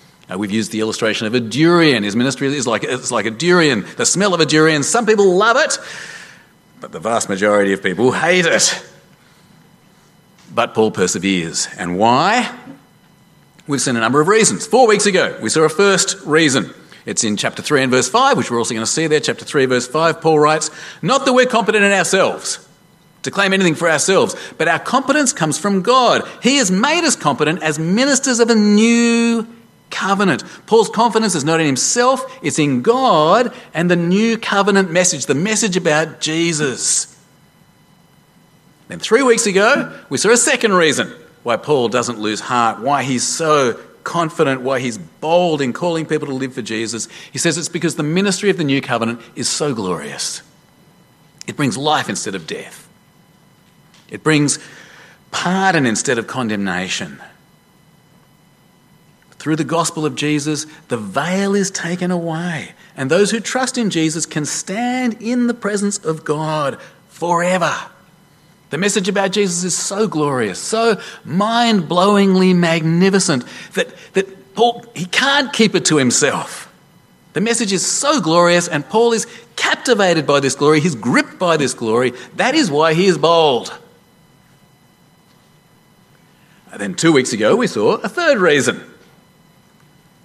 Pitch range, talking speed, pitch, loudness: 150-205 Hz, 165 wpm, 170 Hz, -15 LUFS